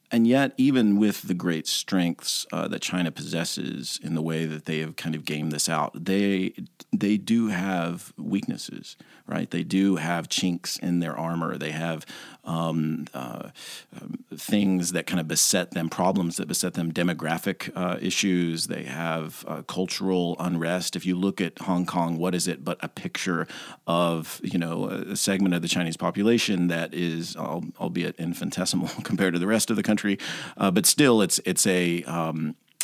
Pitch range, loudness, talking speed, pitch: 85-95 Hz, -26 LUFS, 175 wpm, 85 Hz